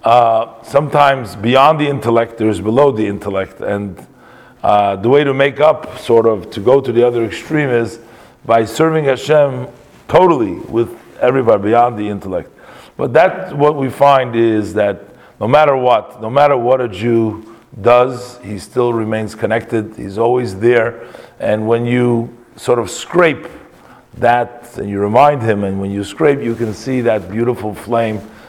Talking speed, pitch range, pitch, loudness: 165 wpm, 110-125 Hz, 115 Hz, -14 LUFS